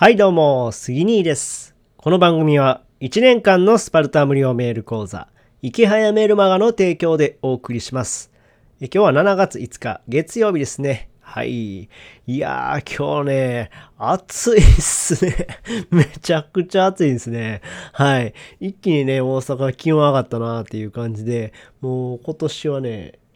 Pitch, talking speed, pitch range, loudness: 140 Hz, 290 characters per minute, 120-175 Hz, -18 LUFS